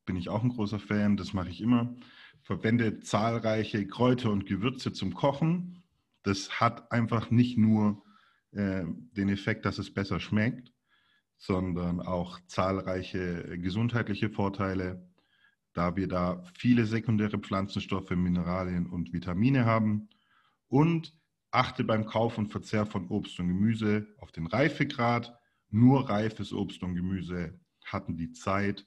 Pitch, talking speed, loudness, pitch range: 105 Hz, 135 wpm, -30 LUFS, 95-115 Hz